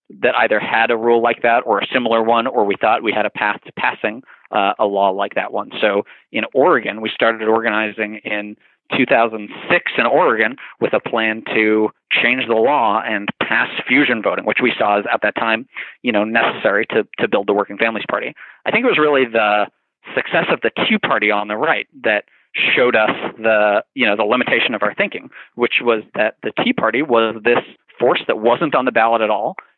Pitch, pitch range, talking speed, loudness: 110 Hz, 105-115 Hz, 210 wpm, -17 LUFS